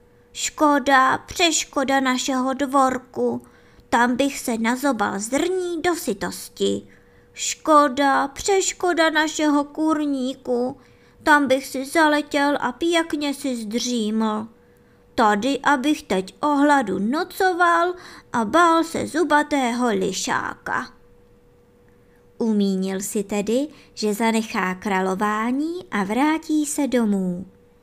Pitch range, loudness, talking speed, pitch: 210-295 Hz, -21 LUFS, 95 wpm, 260 Hz